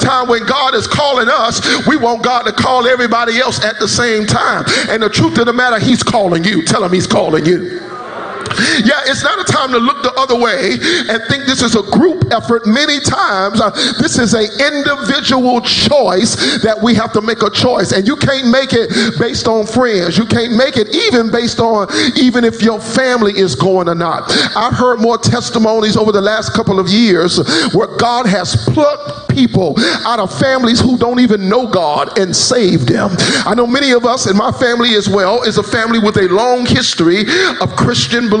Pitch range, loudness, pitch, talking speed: 210-250 Hz, -11 LUFS, 230 Hz, 205 wpm